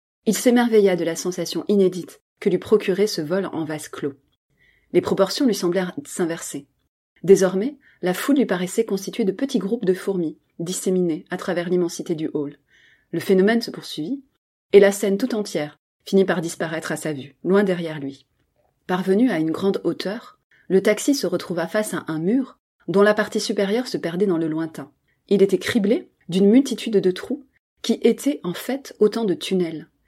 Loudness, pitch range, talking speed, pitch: -21 LUFS, 170-215 Hz, 180 wpm, 190 Hz